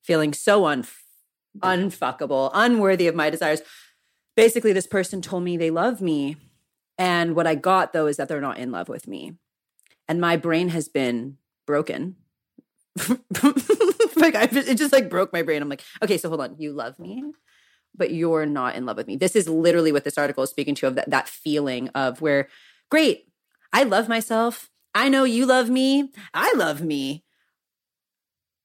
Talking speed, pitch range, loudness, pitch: 180 wpm, 150-230 Hz, -22 LUFS, 170 Hz